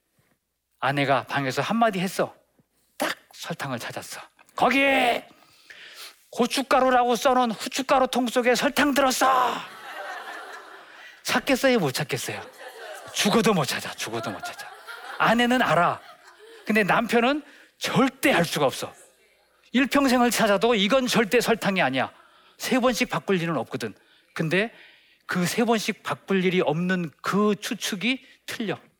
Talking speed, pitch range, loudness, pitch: 260 characters per minute, 195-260 Hz, -23 LUFS, 240 Hz